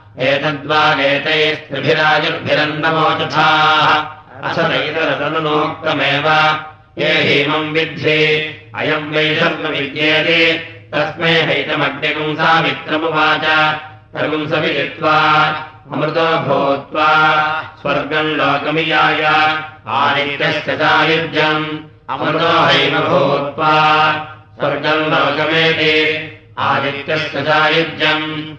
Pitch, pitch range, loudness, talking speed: 155 Hz, 150-155 Hz, -14 LUFS, 50 wpm